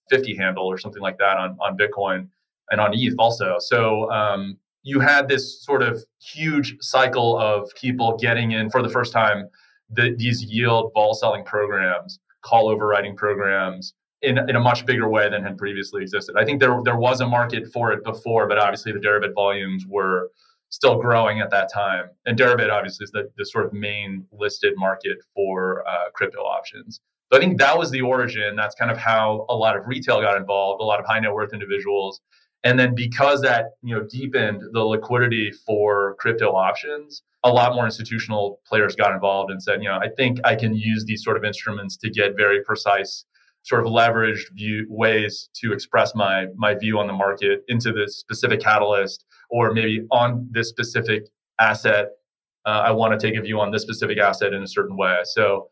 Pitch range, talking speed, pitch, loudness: 100-125 Hz, 200 wpm, 110 Hz, -21 LUFS